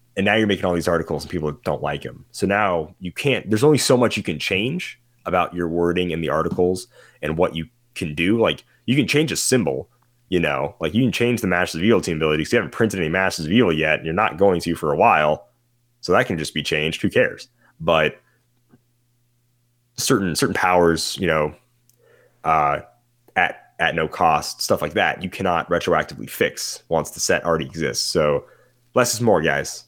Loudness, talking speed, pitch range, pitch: -20 LUFS, 210 wpm, 85-120 Hz, 100 Hz